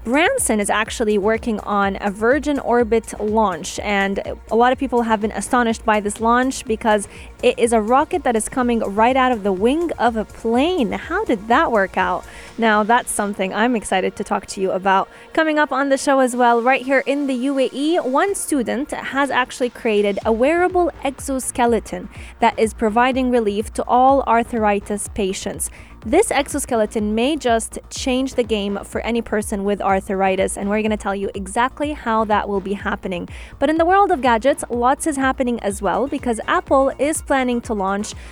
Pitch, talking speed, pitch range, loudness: 235 Hz, 185 wpm, 210-270 Hz, -19 LUFS